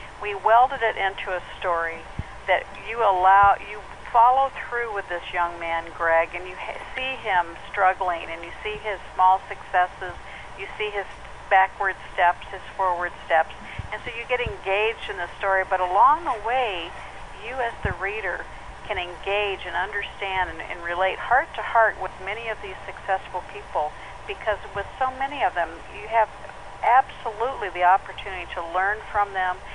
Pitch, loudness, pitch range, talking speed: 195 Hz, -24 LUFS, 180-210 Hz, 170 wpm